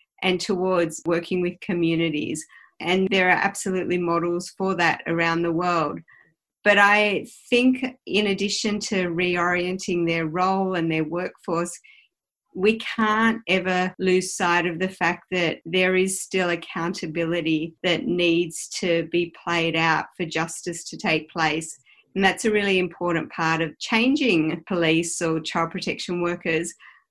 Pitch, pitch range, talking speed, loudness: 175 Hz, 165-190 Hz, 140 wpm, -23 LUFS